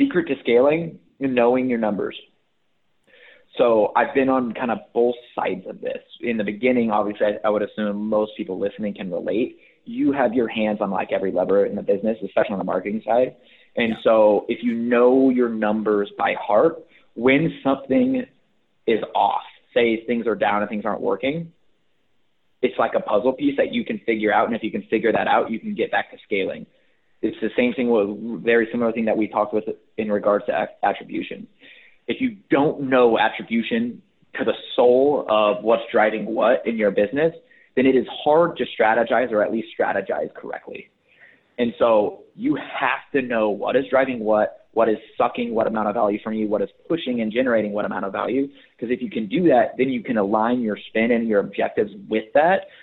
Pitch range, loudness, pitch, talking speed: 105-135 Hz, -21 LUFS, 120 Hz, 200 wpm